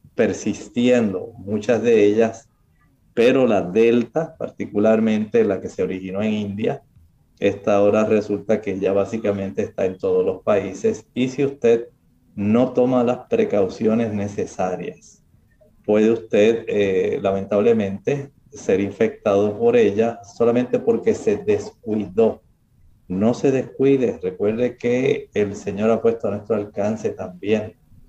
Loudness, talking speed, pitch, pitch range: -20 LUFS, 125 wpm, 110 Hz, 100-125 Hz